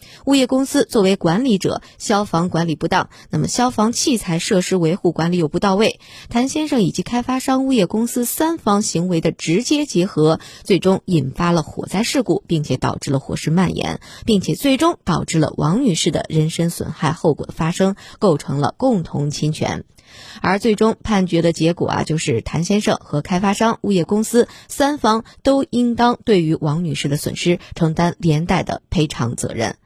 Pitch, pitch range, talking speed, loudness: 180 Hz, 160-225 Hz, 285 characters per minute, -18 LUFS